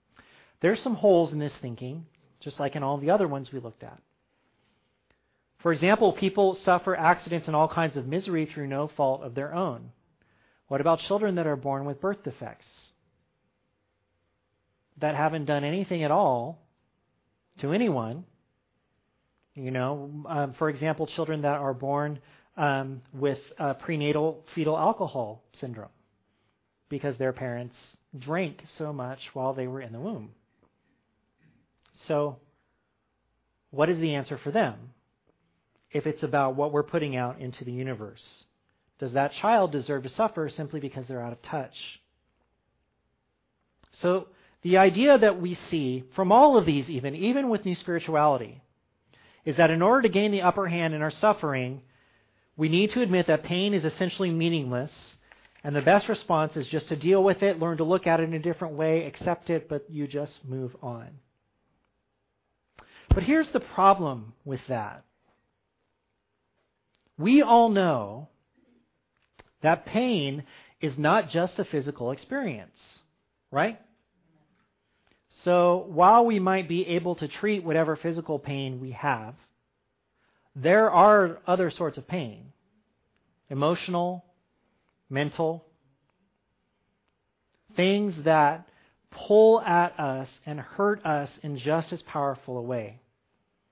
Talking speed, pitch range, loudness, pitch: 140 wpm, 135-180 Hz, -26 LUFS, 155 Hz